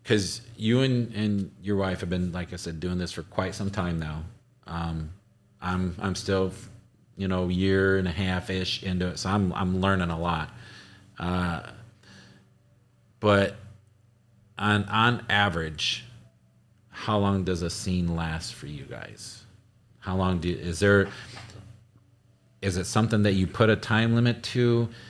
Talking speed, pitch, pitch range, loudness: 160 wpm, 100 Hz, 90-115 Hz, -27 LUFS